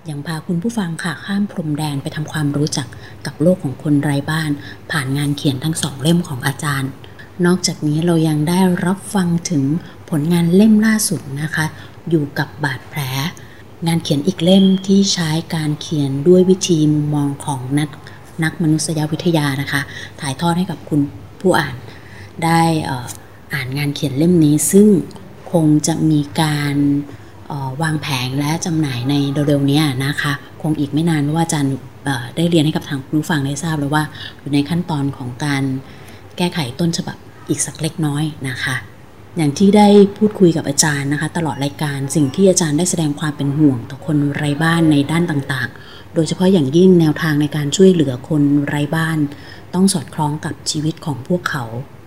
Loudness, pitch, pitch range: -17 LUFS, 150 Hz, 140-165 Hz